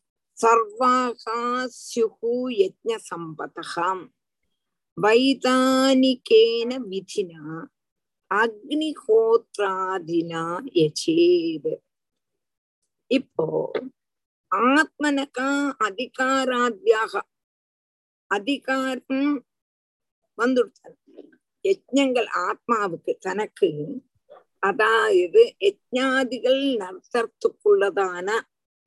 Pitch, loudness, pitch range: 255 Hz, -23 LUFS, 225-315 Hz